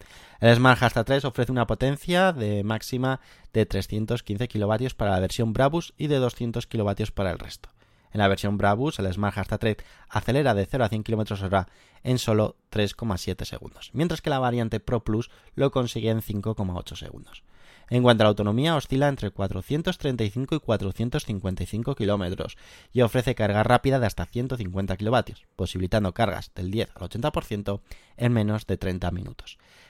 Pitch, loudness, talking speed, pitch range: 110 Hz, -25 LUFS, 165 wpm, 100-125 Hz